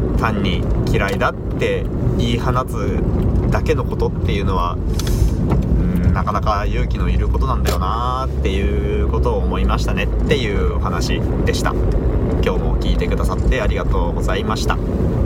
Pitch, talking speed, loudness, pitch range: 85 Hz, 325 characters per minute, -19 LUFS, 65-95 Hz